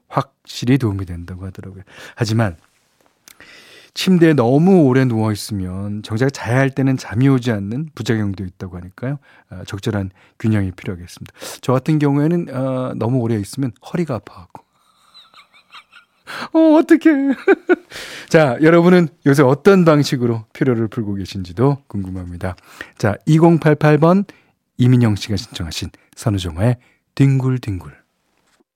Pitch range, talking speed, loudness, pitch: 100-150 Hz, 290 characters per minute, -16 LUFS, 125 Hz